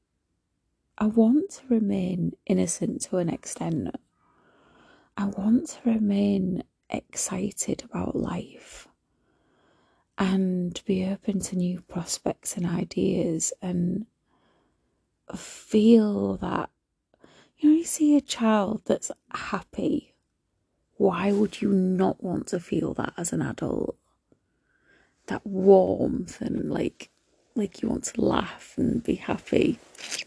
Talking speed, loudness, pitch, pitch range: 115 wpm, -26 LUFS, 200 Hz, 185-225 Hz